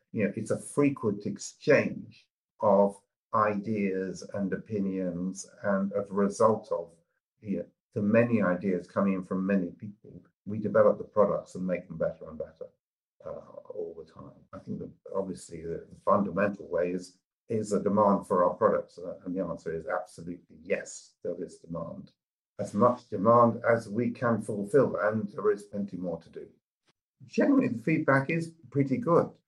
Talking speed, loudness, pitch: 170 wpm, -29 LUFS, 115 Hz